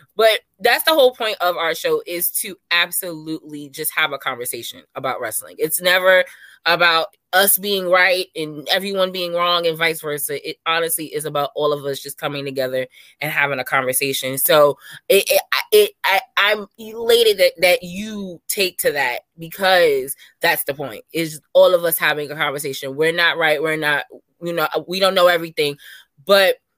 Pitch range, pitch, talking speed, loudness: 150-195 Hz, 170 Hz, 180 wpm, -18 LUFS